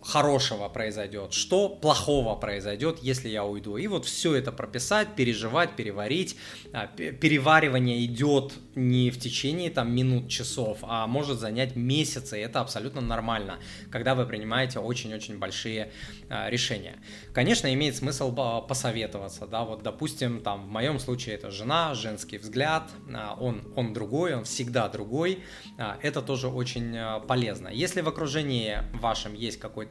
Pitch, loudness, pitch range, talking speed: 125 Hz, -28 LUFS, 110-135 Hz, 135 wpm